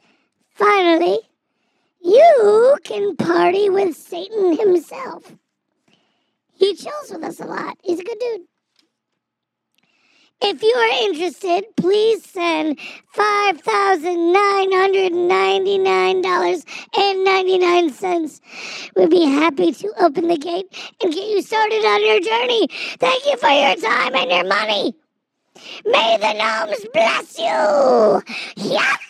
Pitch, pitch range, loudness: 370 Hz, 335-410 Hz, -17 LUFS